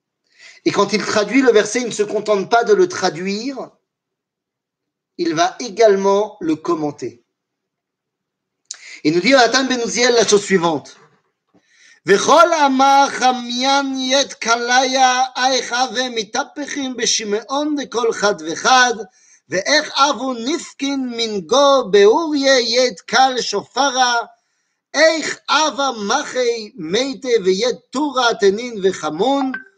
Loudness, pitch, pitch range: -16 LUFS, 255 Hz, 220-285 Hz